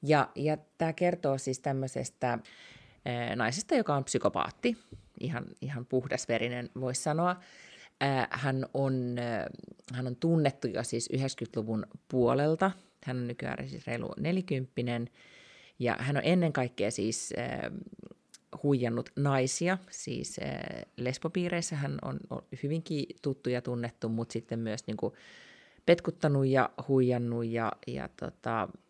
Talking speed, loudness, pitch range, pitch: 130 wpm, -32 LUFS, 120-150 Hz, 130 Hz